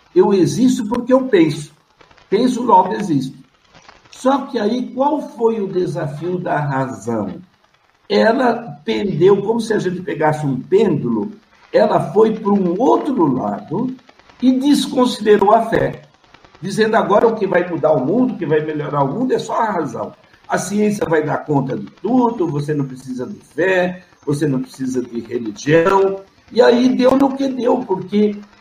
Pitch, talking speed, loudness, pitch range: 195 Hz, 165 wpm, -17 LUFS, 155-245 Hz